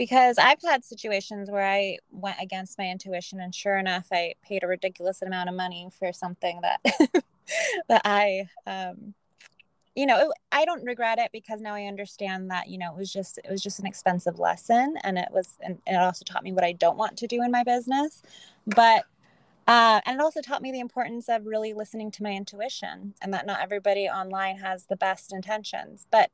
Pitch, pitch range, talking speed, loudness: 200 Hz, 185-235 Hz, 210 wpm, -26 LUFS